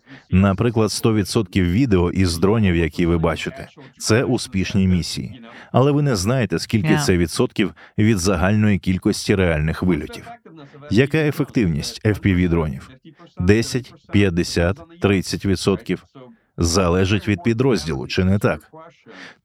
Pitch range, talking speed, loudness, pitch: 90-125 Hz, 110 wpm, -19 LUFS, 100 Hz